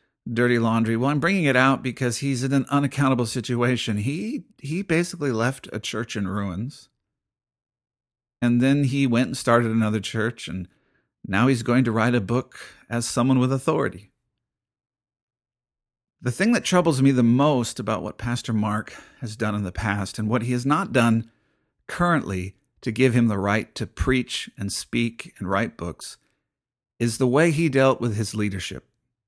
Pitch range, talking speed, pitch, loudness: 110-135 Hz, 170 wpm, 120 Hz, -23 LUFS